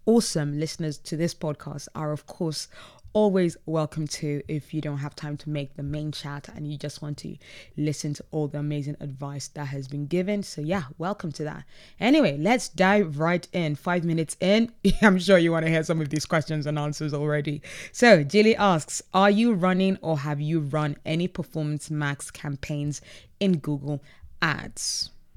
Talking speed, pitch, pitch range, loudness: 185 wpm, 155 Hz, 150-180 Hz, -25 LUFS